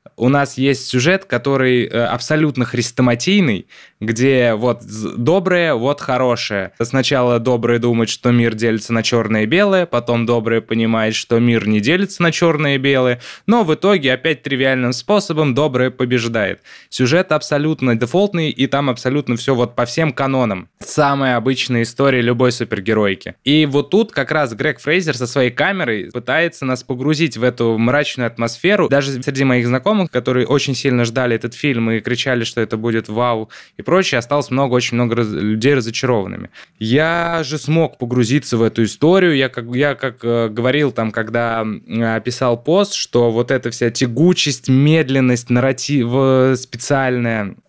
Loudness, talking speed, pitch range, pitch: -16 LUFS, 155 wpm, 120-145 Hz, 125 Hz